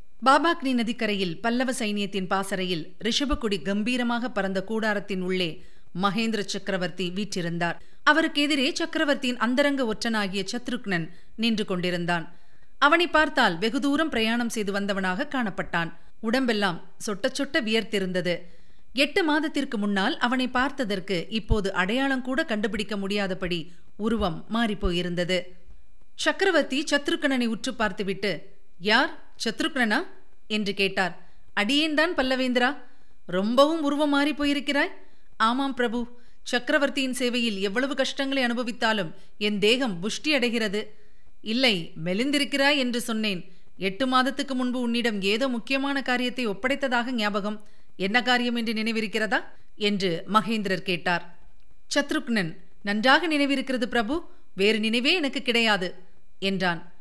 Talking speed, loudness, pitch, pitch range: 105 wpm, -25 LUFS, 225 Hz, 195-265 Hz